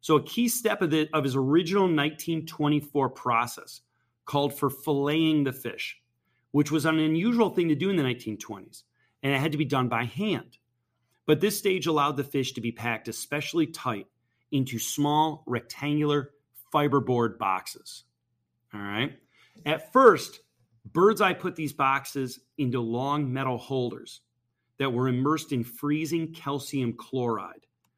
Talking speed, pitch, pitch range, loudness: 150 wpm, 140 Hz, 120-155 Hz, -27 LUFS